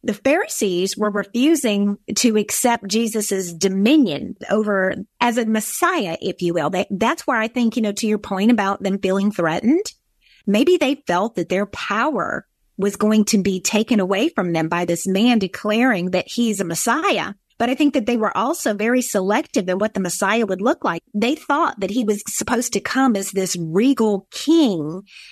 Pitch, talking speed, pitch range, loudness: 215 Hz, 185 wpm, 195-245 Hz, -19 LUFS